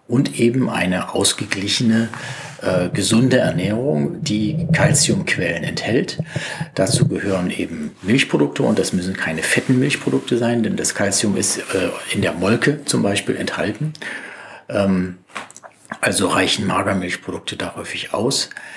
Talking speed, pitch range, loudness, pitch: 125 wpm, 95-130 Hz, -19 LUFS, 115 Hz